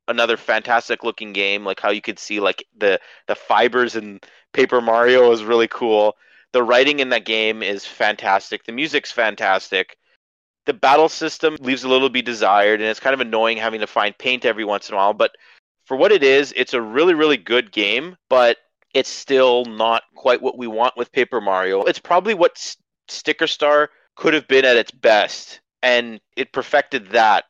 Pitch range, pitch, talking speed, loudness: 110-135 Hz, 120 Hz, 195 wpm, -18 LUFS